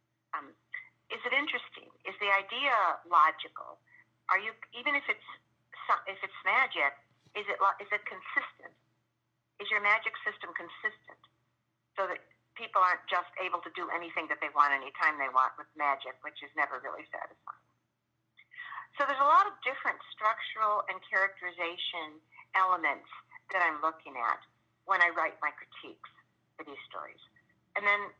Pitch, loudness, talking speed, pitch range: 195 Hz, -31 LUFS, 155 wpm, 150-220 Hz